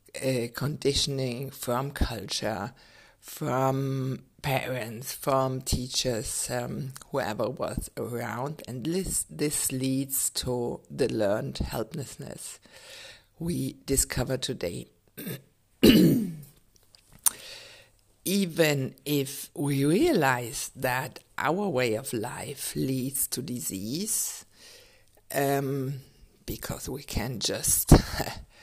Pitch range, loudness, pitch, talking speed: 125-140 Hz, -28 LUFS, 135 Hz, 85 wpm